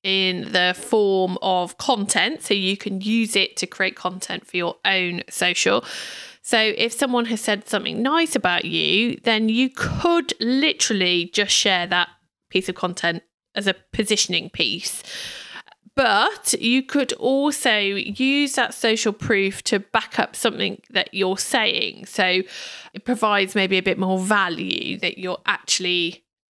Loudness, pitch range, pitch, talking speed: -20 LUFS, 185-230 Hz, 200 Hz, 150 wpm